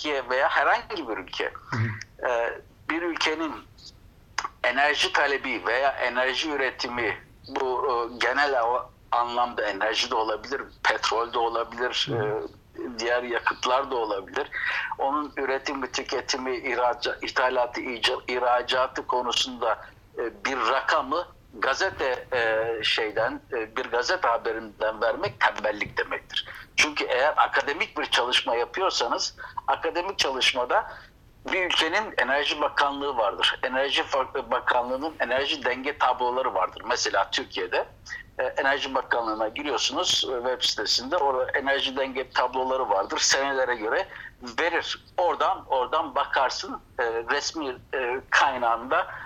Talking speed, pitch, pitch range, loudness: 100 wpm, 125 Hz, 120-135 Hz, -25 LUFS